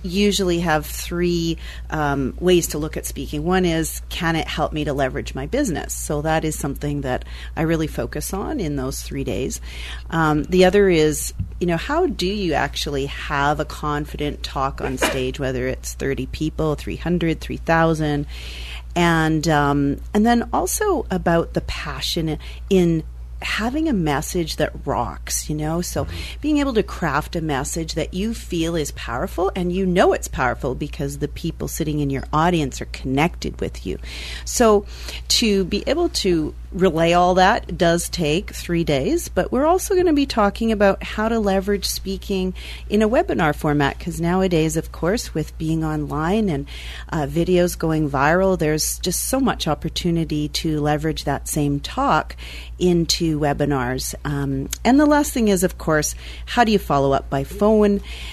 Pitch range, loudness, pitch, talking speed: 145-185 Hz, -21 LUFS, 160 Hz, 170 wpm